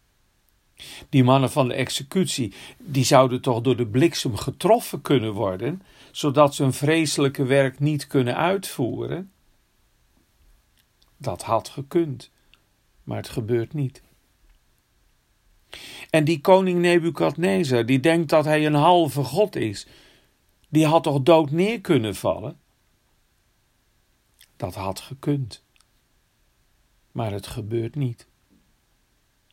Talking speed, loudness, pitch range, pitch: 110 wpm, -22 LUFS, 125-165 Hz, 140 Hz